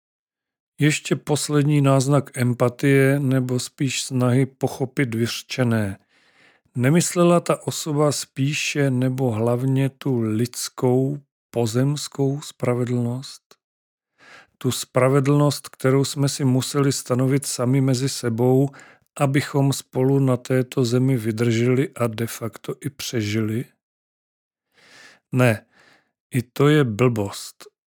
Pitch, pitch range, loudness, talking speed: 130 Hz, 125-140 Hz, -21 LUFS, 95 wpm